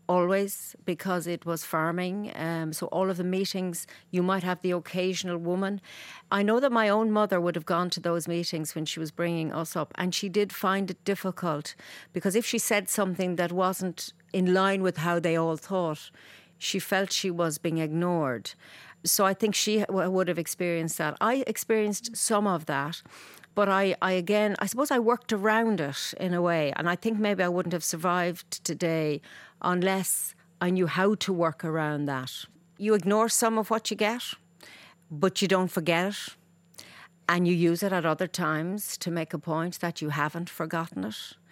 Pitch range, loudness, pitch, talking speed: 170-195 Hz, -28 LUFS, 180 Hz, 190 wpm